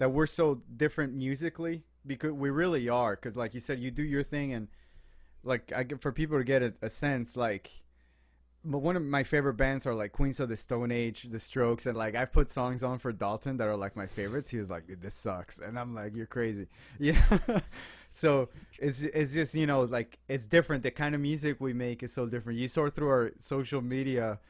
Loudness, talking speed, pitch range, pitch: -32 LUFS, 225 wpm, 115-145 Hz, 130 Hz